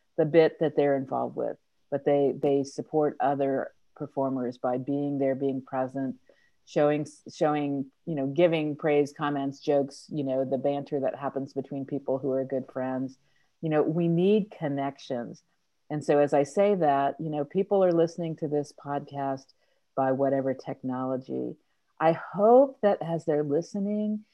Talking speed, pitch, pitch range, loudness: 160 wpm, 145 Hz, 135-155 Hz, -27 LUFS